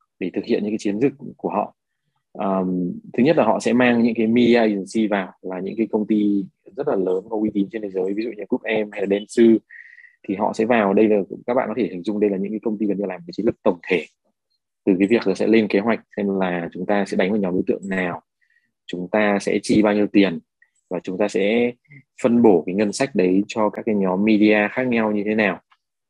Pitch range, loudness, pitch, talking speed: 100-115 Hz, -20 LUFS, 105 Hz, 265 wpm